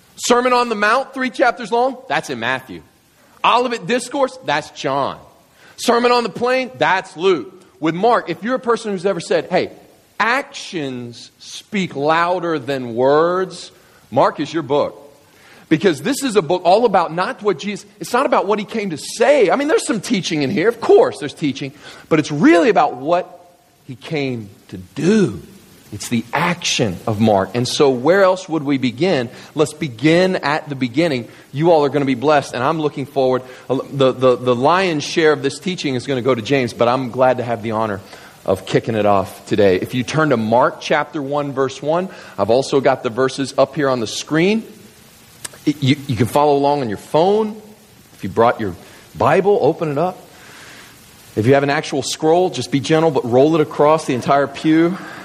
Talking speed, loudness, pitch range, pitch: 200 wpm, -17 LUFS, 130-190 Hz, 155 Hz